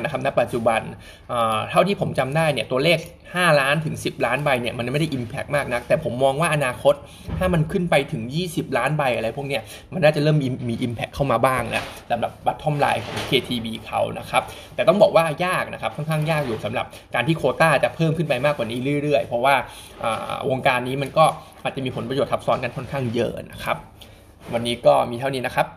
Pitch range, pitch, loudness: 120-155 Hz, 135 Hz, -22 LUFS